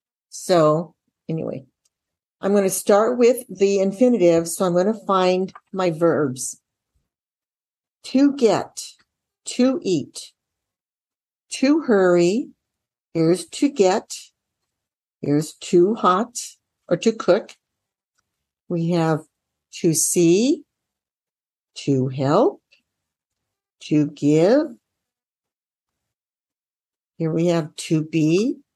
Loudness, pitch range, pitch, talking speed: -20 LUFS, 155-210 Hz, 175 Hz, 90 wpm